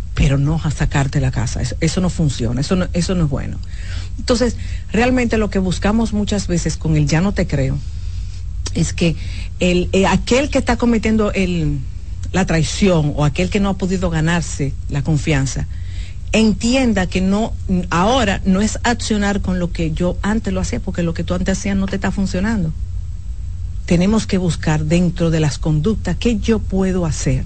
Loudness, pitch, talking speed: -18 LUFS, 160 Hz, 185 wpm